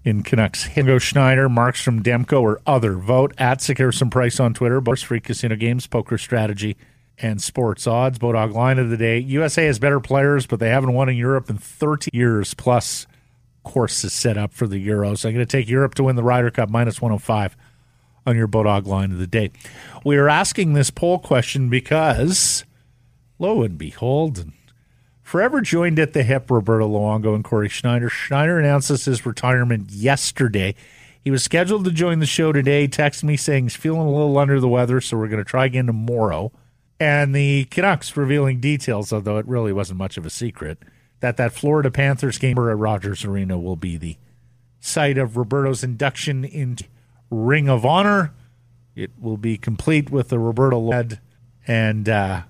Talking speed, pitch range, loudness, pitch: 185 wpm, 115-140 Hz, -19 LUFS, 125 Hz